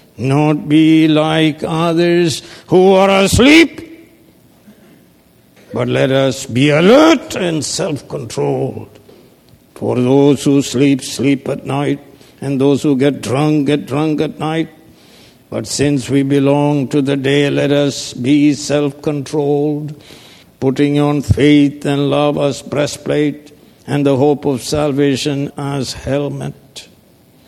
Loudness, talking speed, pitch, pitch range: -14 LUFS, 125 wpm, 145 Hz, 140-150 Hz